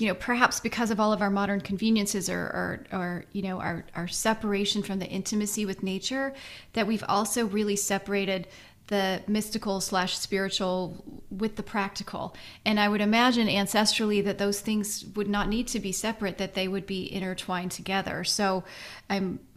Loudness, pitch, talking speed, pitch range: -28 LUFS, 200 Hz, 175 wpm, 190-215 Hz